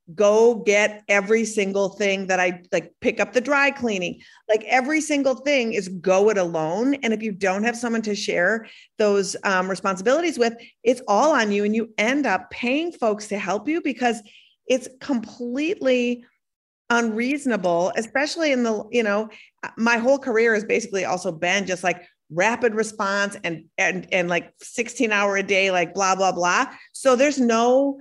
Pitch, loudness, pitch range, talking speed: 220 Hz, -21 LUFS, 195-245 Hz, 175 wpm